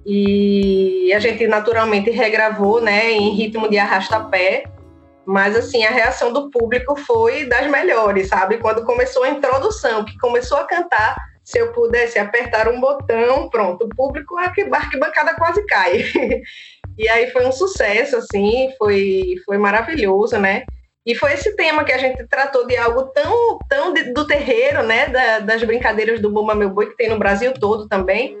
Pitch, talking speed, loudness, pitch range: 235 Hz, 165 wpm, -16 LUFS, 210-295 Hz